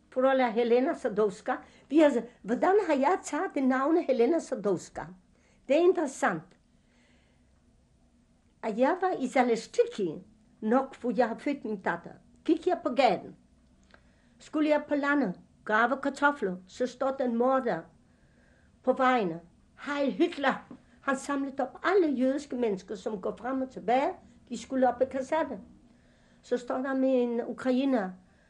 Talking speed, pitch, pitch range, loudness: 145 wpm, 260 Hz, 240-285 Hz, -29 LUFS